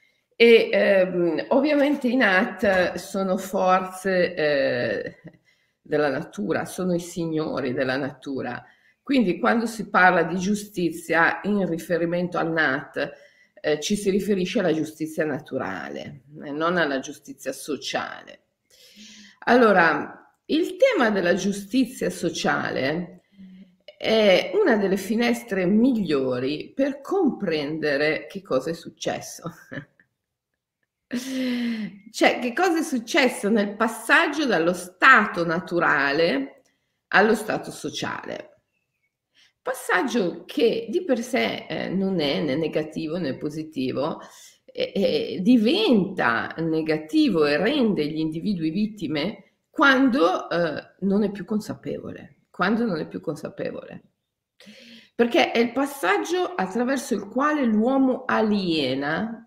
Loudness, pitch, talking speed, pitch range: -23 LUFS, 195 Hz, 110 wpm, 165-250 Hz